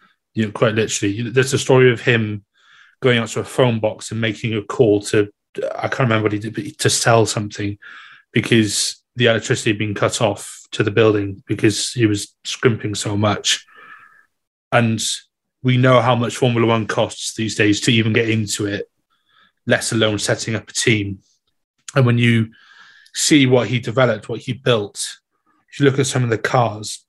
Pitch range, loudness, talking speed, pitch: 105-125 Hz, -18 LUFS, 190 wpm, 115 Hz